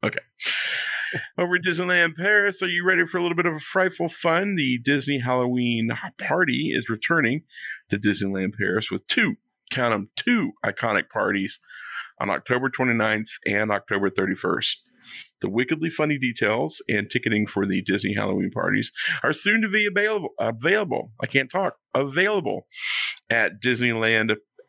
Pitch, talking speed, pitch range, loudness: 145 Hz, 150 wpm, 120-180 Hz, -23 LUFS